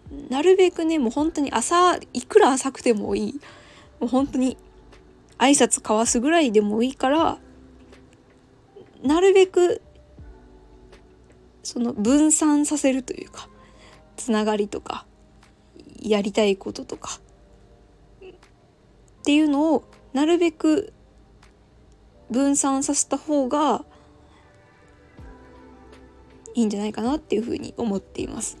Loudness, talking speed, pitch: -21 LUFS, 225 characters per minute, 245 Hz